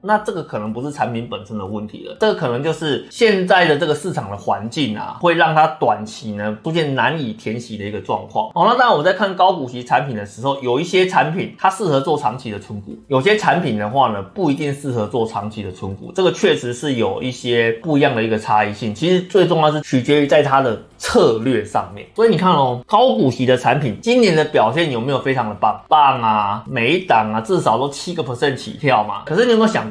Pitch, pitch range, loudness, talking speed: 140 Hz, 110-175 Hz, -17 LUFS, 365 characters per minute